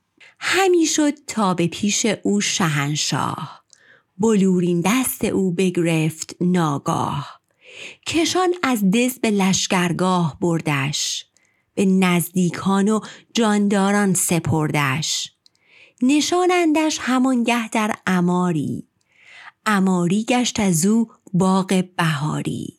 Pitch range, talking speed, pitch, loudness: 175-240 Hz, 90 wpm, 190 Hz, -19 LUFS